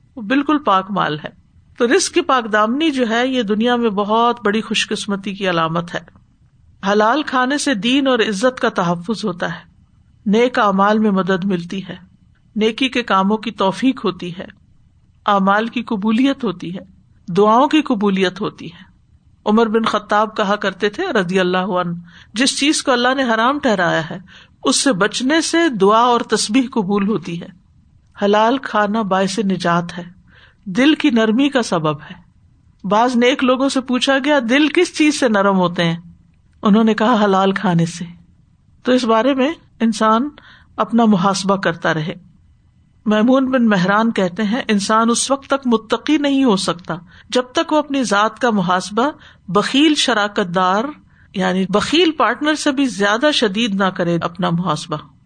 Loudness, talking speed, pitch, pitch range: -16 LUFS, 170 wpm, 215 Hz, 190-255 Hz